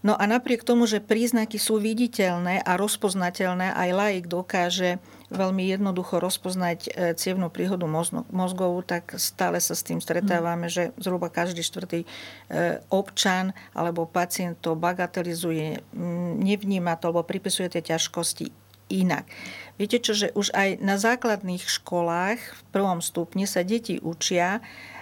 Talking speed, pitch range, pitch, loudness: 130 wpm, 170-200 Hz, 180 Hz, -26 LUFS